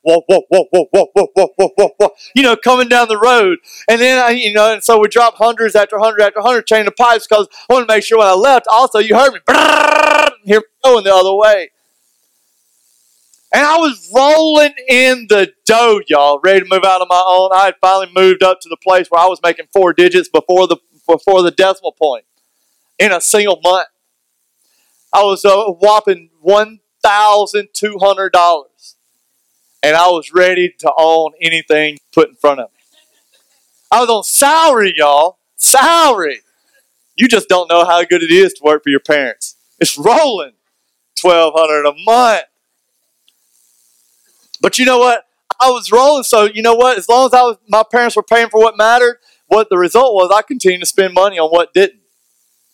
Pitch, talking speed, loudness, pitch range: 200 Hz, 180 wpm, -10 LUFS, 175-235 Hz